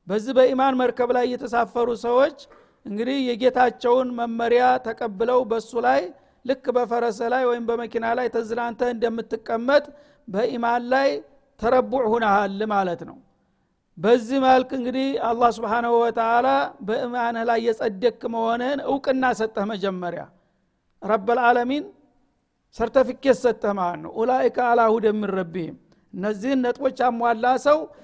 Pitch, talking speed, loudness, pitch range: 240 Hz, 110 wpm, -22 LUFS, 230-255 Hz